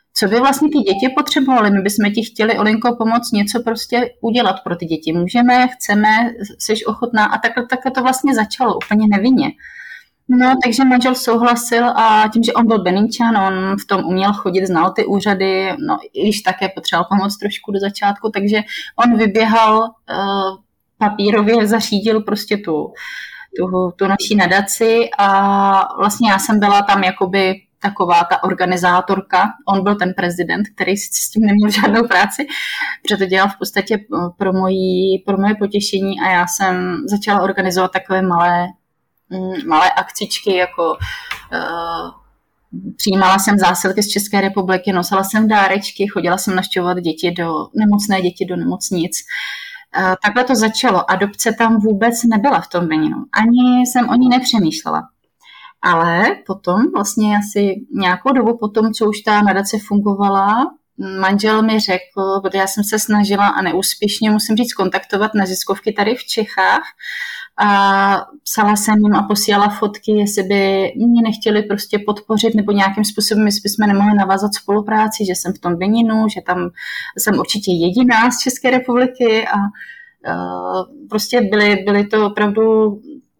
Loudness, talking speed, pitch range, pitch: -15 LUFS, 150 wpm, 195-230 Hz, 210 Hz